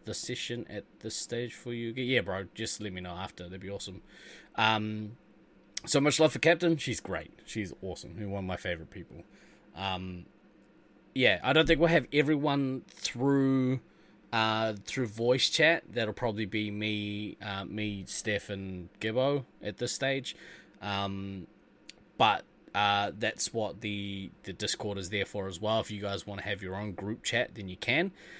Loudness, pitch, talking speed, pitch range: -31 LUFS, 105 Hz, 175 wpm, 100-125 Hz